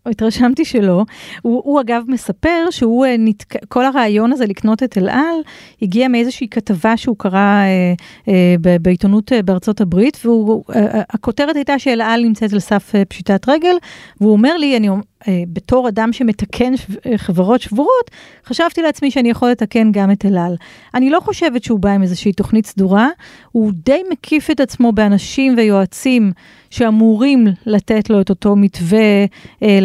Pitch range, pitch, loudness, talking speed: 200-255 Hz, 225 Hz, -14 LUFS, 150 wpm